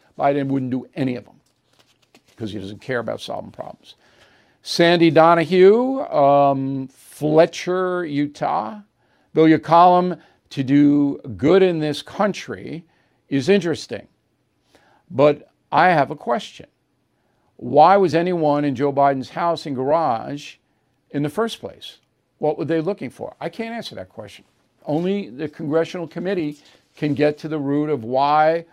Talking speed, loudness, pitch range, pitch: 140 wpm, -19 LUFS, 135-170 Hz, 150 Hz